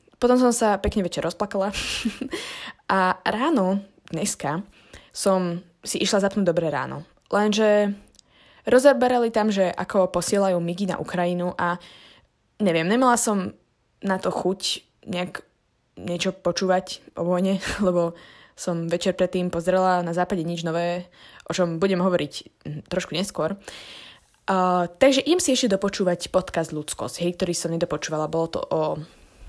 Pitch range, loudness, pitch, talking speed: 175-205 Hz, -23 LUFS, 185 Hz, 135 wpm